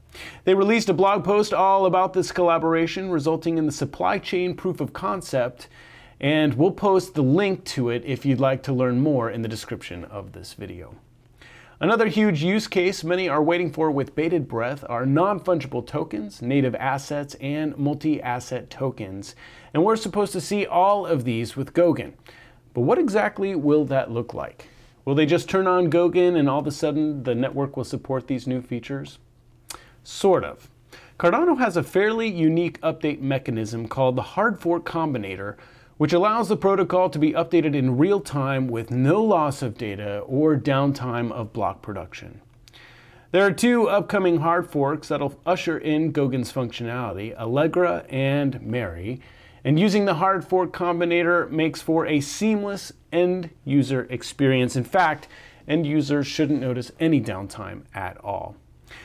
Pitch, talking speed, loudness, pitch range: 145 Hz, 165 wpm, -23 LUFS, 125-175 Hz